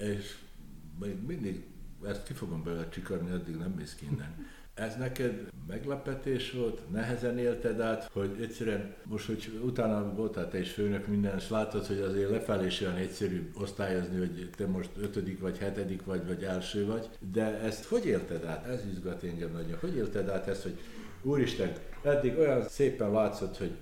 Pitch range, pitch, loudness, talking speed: 95-110 Hz, 100 Hz, -34 LUFS, 170 wpm